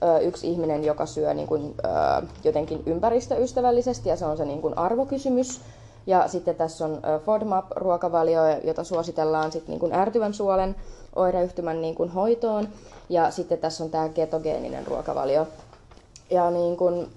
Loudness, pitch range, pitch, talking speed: -25 LUFS, 155-190 Hz, 170 Hz, 145 wpm